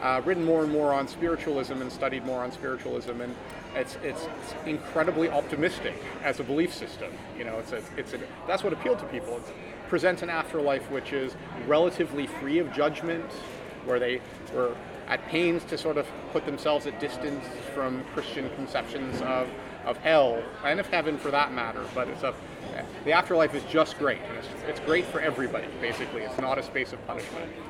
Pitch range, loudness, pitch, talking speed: 130-165 Hz, -29 LUFS, 145 Hz, 190 wpm